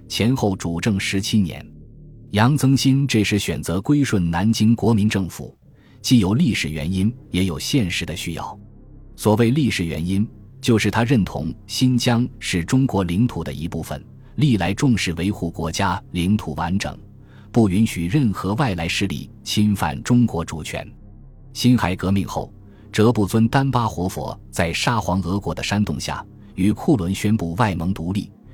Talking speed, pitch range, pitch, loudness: 240 characters per minute, 90-120 Hz, 105 Hz, -20 LUFS